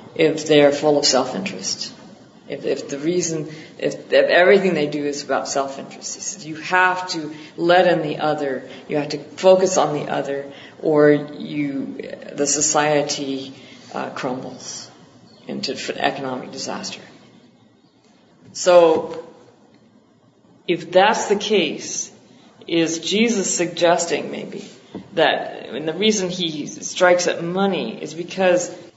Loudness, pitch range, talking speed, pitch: -19 LUFS, 145-180 Hz, 130 wpm, 160 Hz